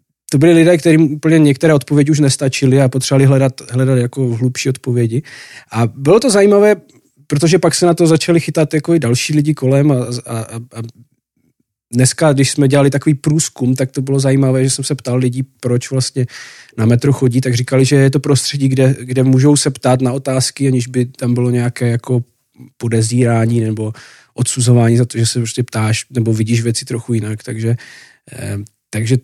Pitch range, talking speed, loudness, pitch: 120-140 Hz, 185 wpm, -14 LUFS, 130 Hz